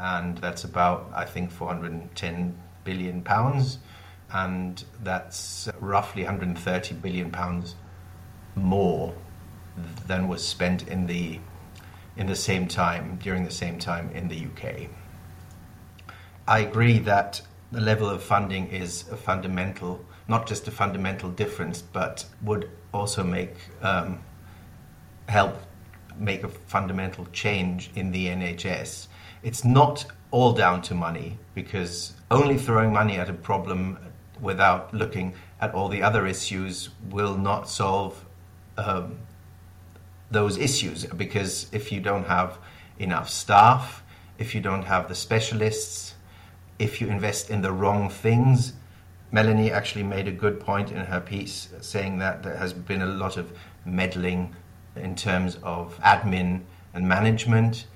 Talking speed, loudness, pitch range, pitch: 140 wpm, -26 LUFS, 90-100 Hz, 95 Hz